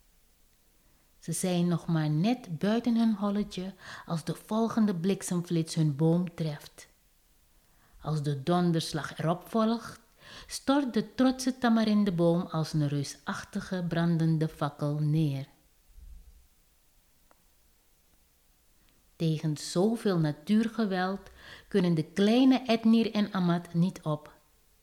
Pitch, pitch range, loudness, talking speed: 165 Hz, 145-200 Hz, -29 LUFS, 100 wpm